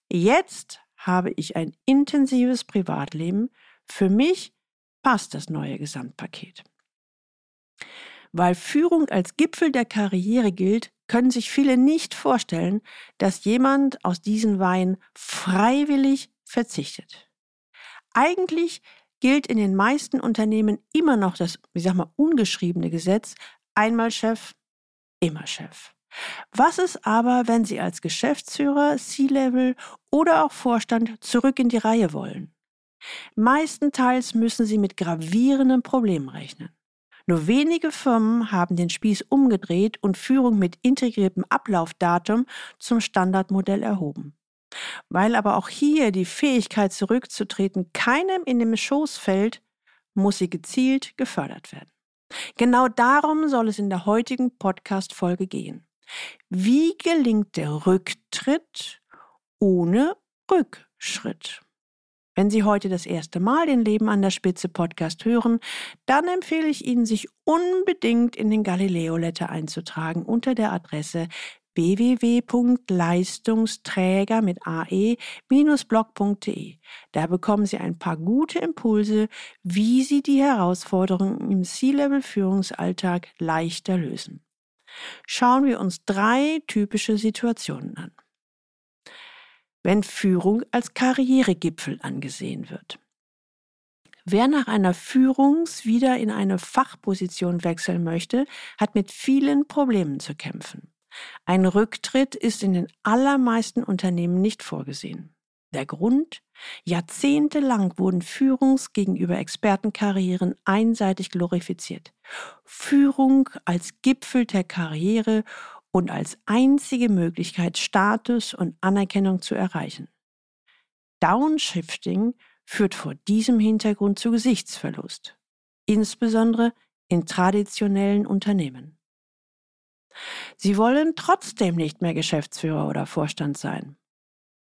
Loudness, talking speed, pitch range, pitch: -22 LUFS, 110 wpm, 185-260 Hz, 215 Hz